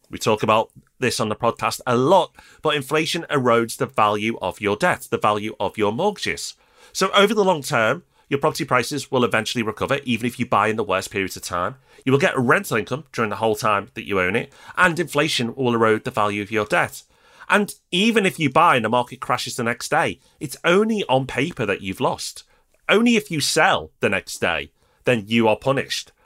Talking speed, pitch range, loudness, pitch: 215 wpm, 110-155 Hz, -21 LUFS, 125 Hz